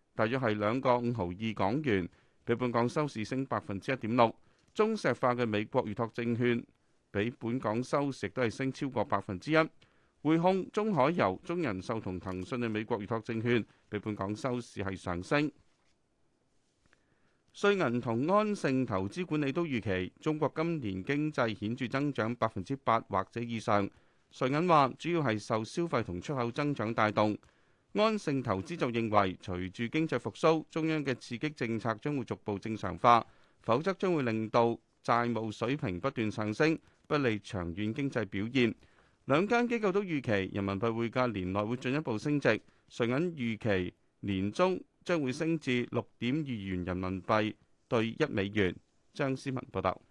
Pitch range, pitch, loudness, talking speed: 105-140 Hz, 120 Hz, -32 LUFS, 255 characters per minute